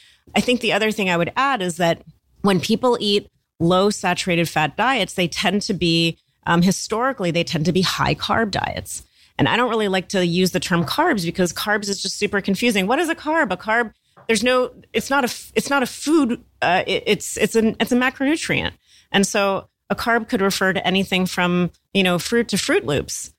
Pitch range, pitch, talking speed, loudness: 180-235 Hz, 200 Hz, 215 wpm, -20 LUFS